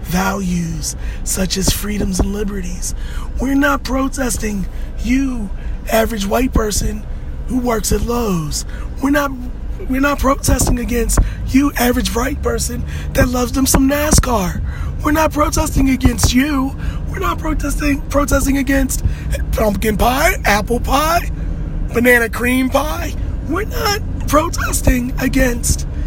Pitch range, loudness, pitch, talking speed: 200-275 Hz, -17 LUFS, 245 Hz, 120 wpm